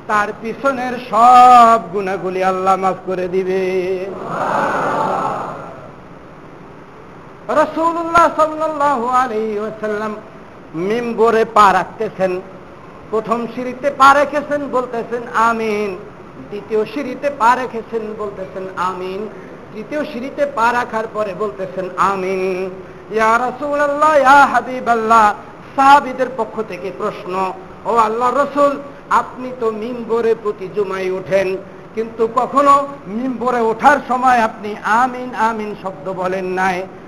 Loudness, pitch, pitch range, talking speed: -16 LUFS, 220 Hz, 190-250 Hz, 100 wpm